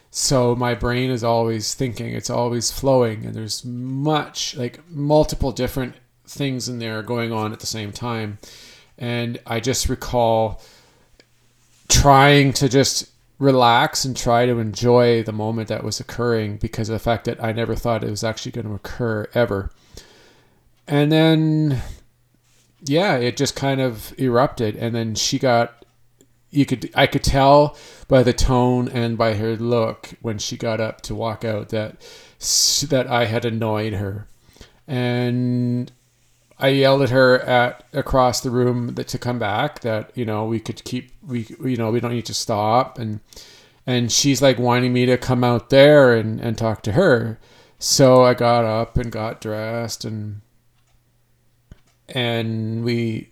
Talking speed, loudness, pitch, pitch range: 165 wpm, -19 LUFS, 120 Hz, 115-130 Hz